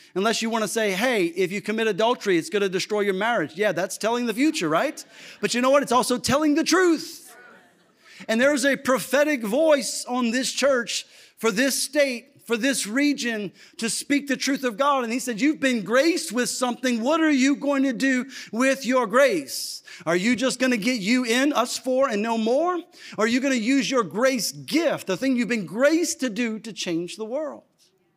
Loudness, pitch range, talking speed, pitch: -23 LUFS, 225-275 Hz, 215 wpm, 250 Hz